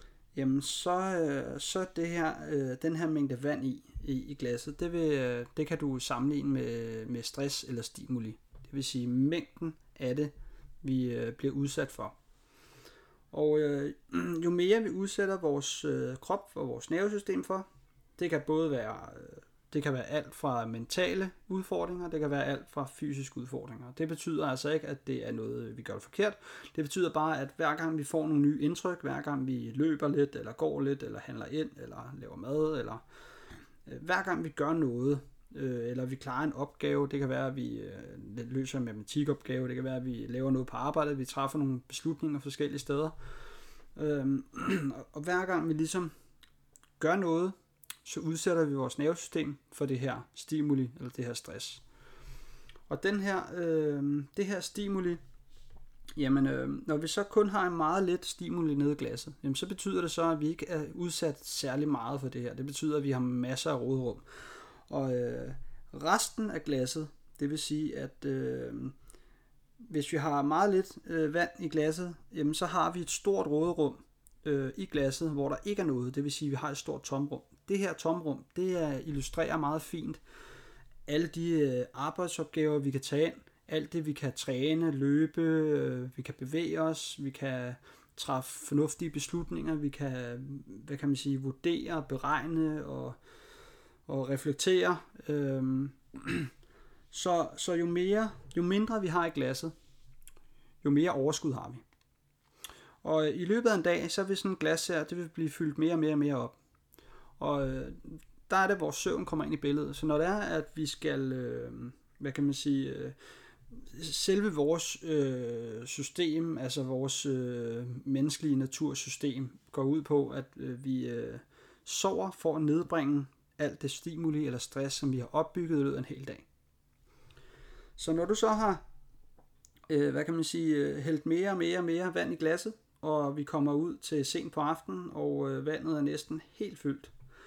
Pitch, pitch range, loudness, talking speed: 150 Hz, 135-160 Hz, -33 LUFS, 175 wpm